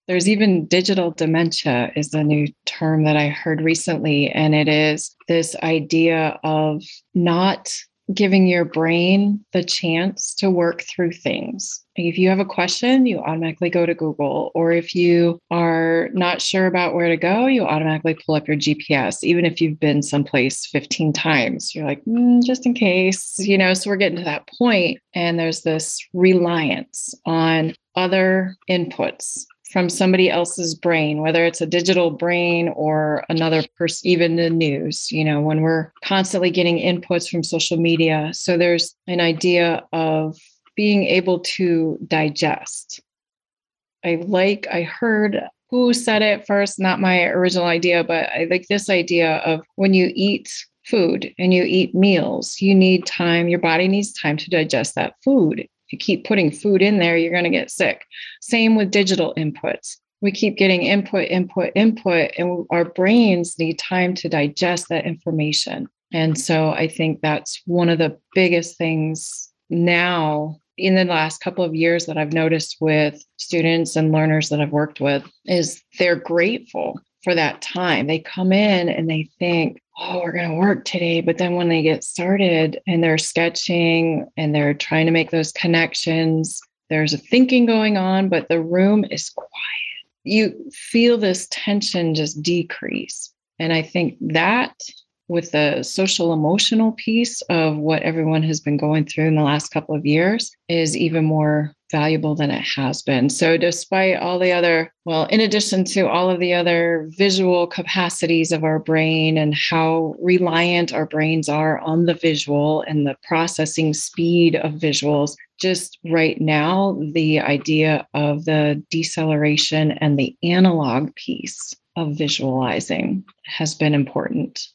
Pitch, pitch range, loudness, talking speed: 170 Hz, 155-185 Hz, -19 LUFS, 165 wpm